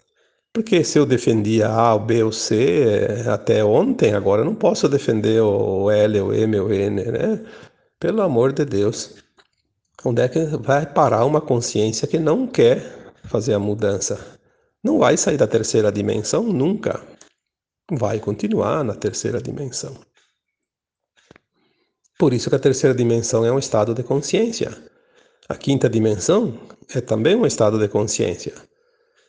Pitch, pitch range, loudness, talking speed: 120 Hz, 110-160 Hz, -19 LUFS, 150 wpm